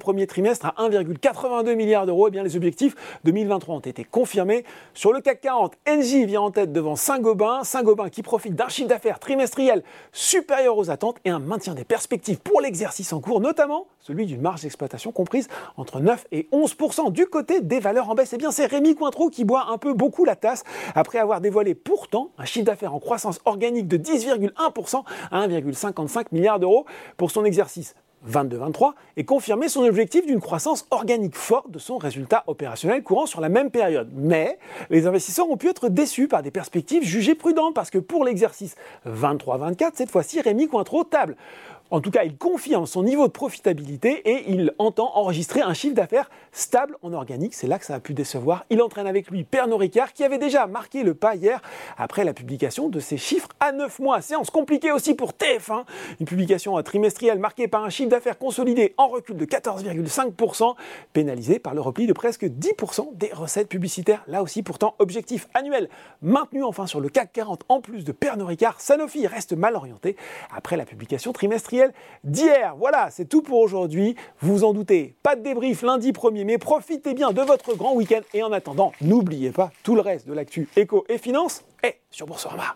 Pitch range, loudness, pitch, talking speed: 185-265 Hz, -22 LUFS, 225 Hz, 195 wpm